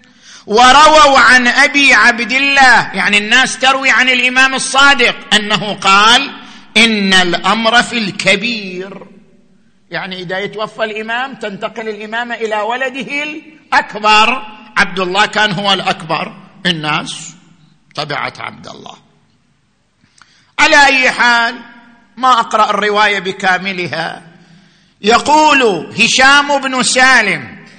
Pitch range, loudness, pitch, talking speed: 195-255 Hz, -10 LUFS, 220 Hz, 100 wpm